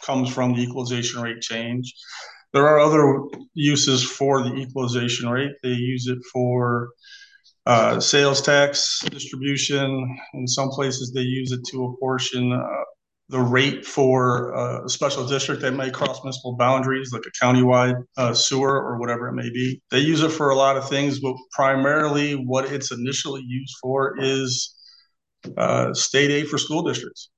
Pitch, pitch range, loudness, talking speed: 130 Hz, 125-140 Hz, -21 LUFS, 160 wpm